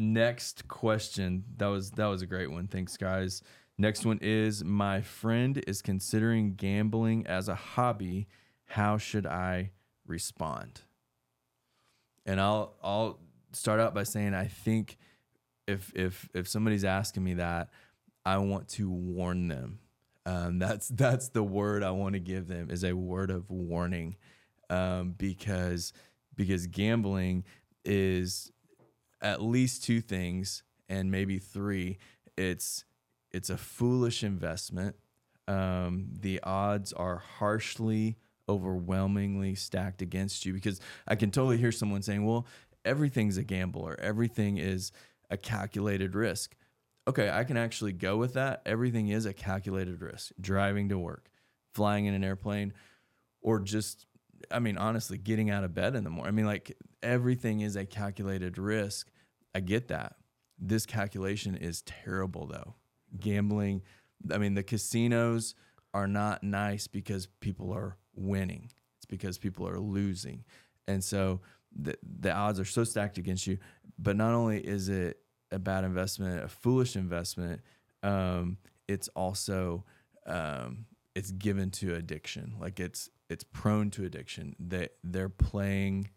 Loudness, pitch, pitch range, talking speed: -33 LUFS, 100 Hz, 95-110 Hz, 145 wpm